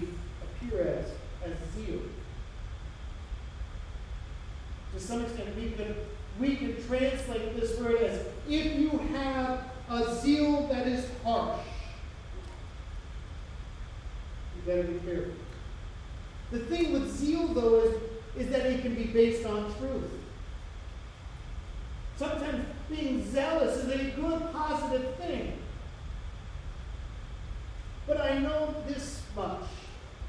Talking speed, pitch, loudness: 105 wpm, 225 Hz, -32 LUFS